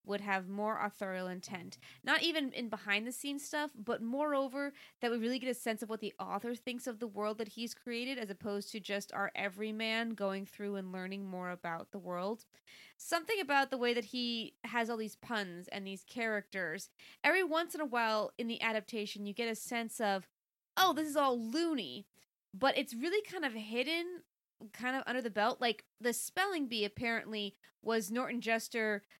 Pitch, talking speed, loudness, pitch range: 230 Hz, 195 wpm, -37 LUFS, 205-255 Hz